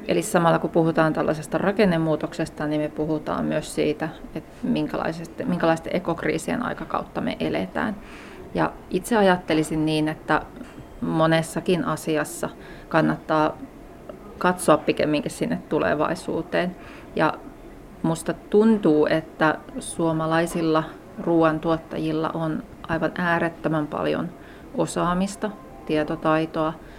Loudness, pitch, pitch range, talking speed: -24 LUFS, 160 Hz, 155-170 Hz, 90 wpm